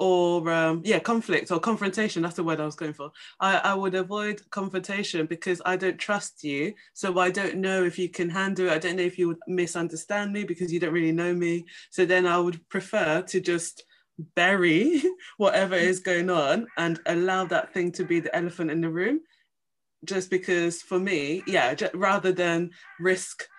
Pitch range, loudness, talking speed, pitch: 170-195 Hz, -26 LUFS, 200 wpm, 180 Hz